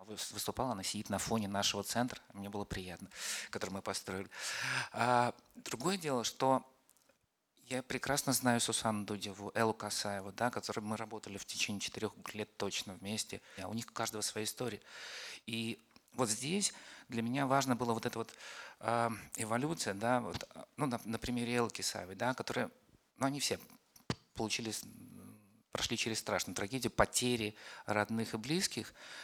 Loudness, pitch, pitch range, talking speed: -37 LUFS, 115 Hz, 105-125 Hz, 150 wpm